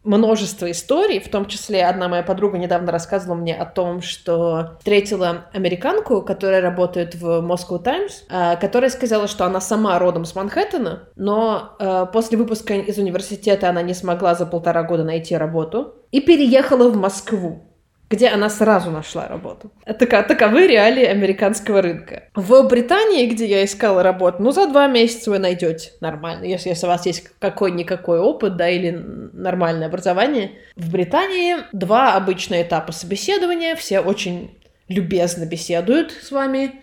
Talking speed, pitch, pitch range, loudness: 150 wpm, 195 Hz, 175-225 Hz, -18 LUFS